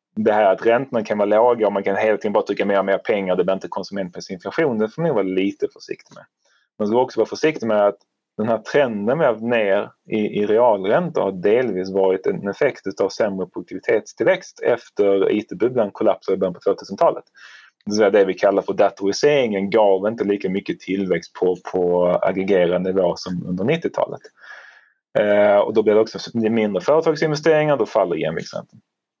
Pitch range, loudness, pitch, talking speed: 95-130 Hz, -19 LUFS, 100 Hz, 180 wpm